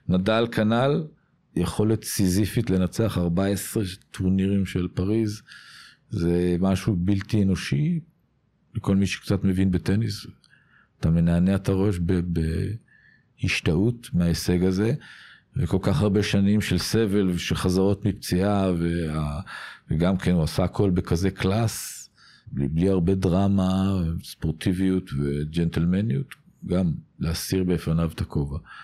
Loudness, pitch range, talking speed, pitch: -24 LUFS, 90-105 Hz, 110 wpm, 95 Hz